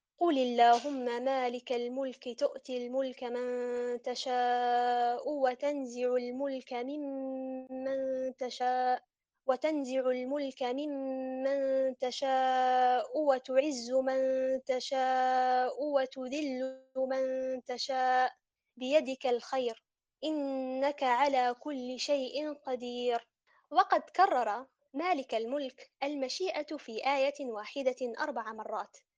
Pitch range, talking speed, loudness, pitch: 250-275 Hz, 80 wpm, -32 LUFS, 260 Hz